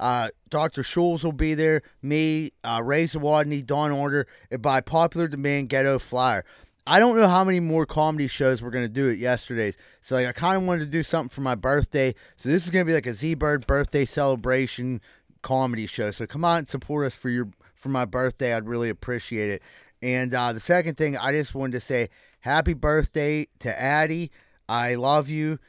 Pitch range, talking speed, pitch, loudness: 125-155 Hz, 205 wpm, 140 Hz, -24 LUFS